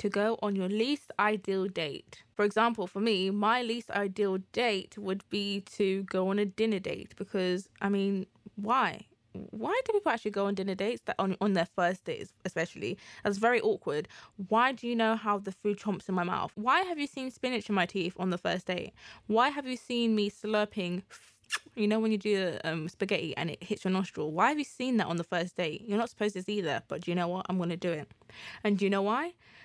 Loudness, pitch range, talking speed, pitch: -31 LUFS, 185-225 Hz, 235 wpm, 205 Hz